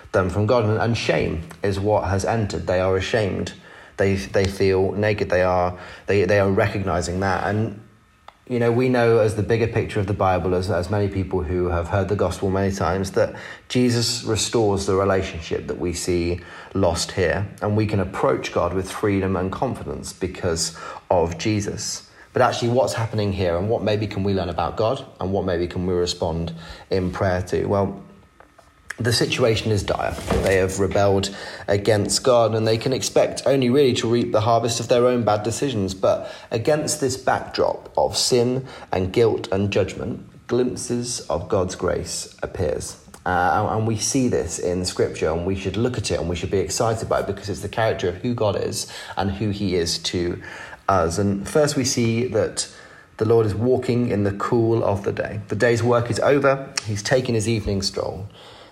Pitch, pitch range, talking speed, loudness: 100 Hz, 95-115 Hz, 195 wpm, -22 LUFS